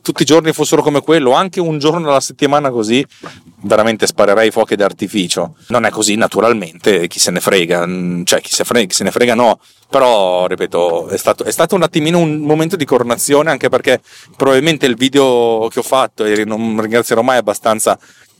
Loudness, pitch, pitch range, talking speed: -13 LUFS, 140 Hz, 115-160 Hz, 190 wpm